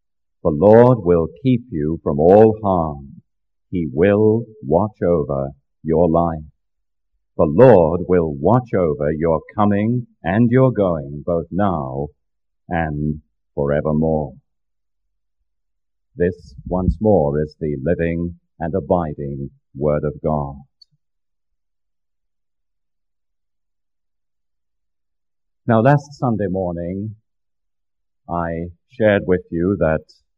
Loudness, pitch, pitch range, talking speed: -18 LUFS, 75 Hz, 65-90 Hz, 95 wpm